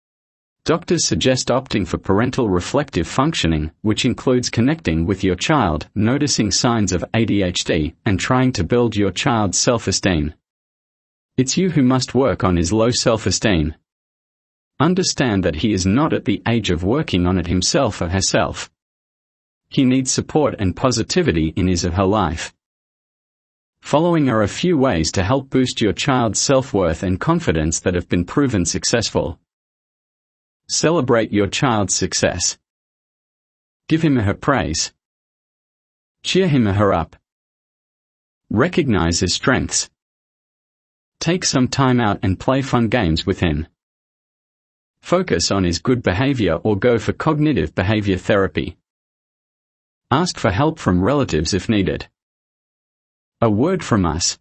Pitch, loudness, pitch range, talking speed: 105 Hz, -18 LUFS, 90-130 Hz, 135 wpm